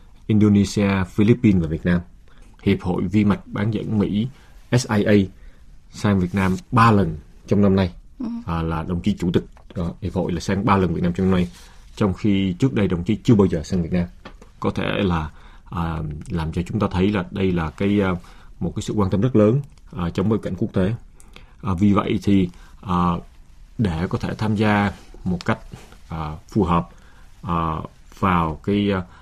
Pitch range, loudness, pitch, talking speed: 85-105 Hz, -21 LUFS, 95 Hz, 195 wpm